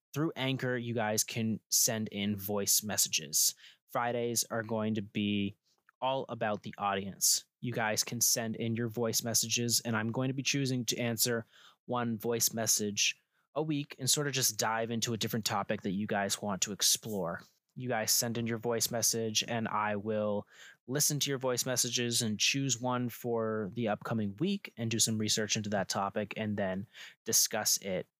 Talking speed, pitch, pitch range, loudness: 185 wpm, 115 Hz, 110-125 Hz, -31 LUFS